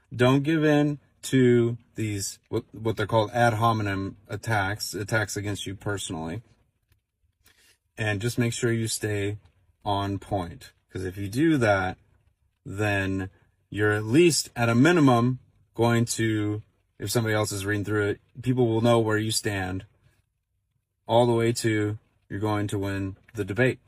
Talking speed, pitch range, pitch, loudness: 155 wpm, 100-120 Hz, 110 Hz, -25 LUFS